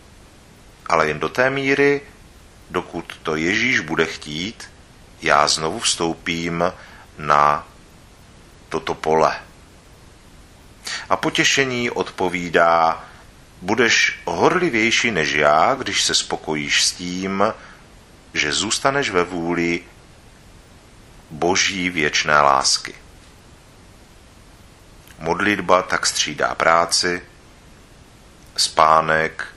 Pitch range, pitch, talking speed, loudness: 80-95 Hz, 85 Hz, 80 wpm, -18 LUFS